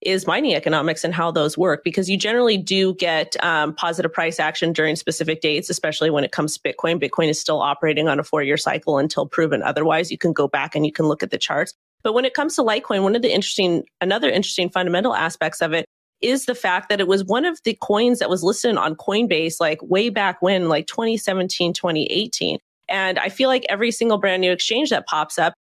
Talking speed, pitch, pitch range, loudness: 225 wpm, 180 Hz, 160-205 Hz, -20 LUFS